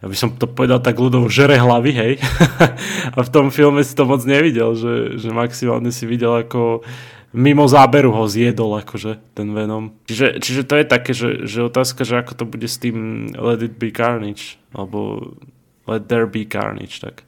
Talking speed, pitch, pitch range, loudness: 190 wpm, 120 Hz, 115-135 Hz, -16 LUFS